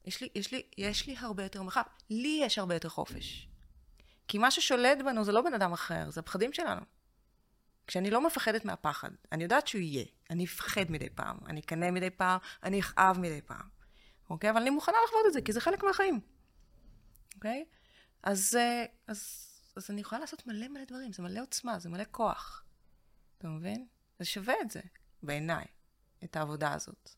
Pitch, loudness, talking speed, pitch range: 200 Hz, -33 LUFS, 185 wpm, 165-240 Hz